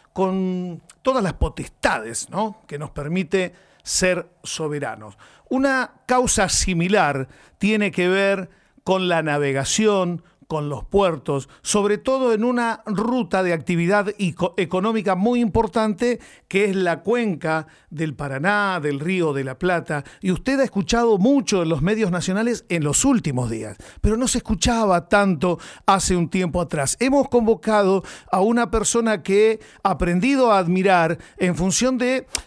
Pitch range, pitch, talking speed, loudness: 170-220 Hz, 190 Hz, 145 wpm, -21 LUFS